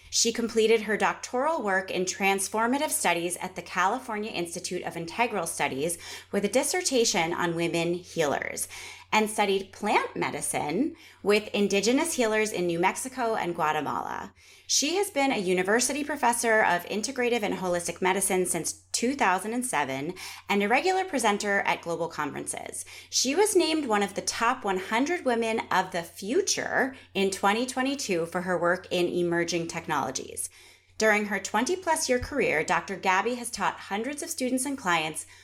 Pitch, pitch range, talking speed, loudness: 205 Hz, 180-245 Hz, 145 wpm, -27 LUFS